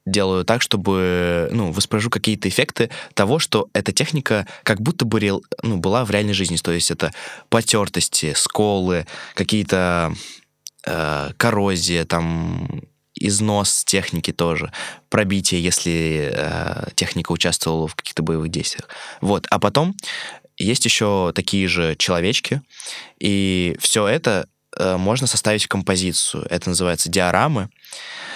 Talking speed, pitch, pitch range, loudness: 125 wpm, 95 Hz, 85-105 Hz, -19 LUFS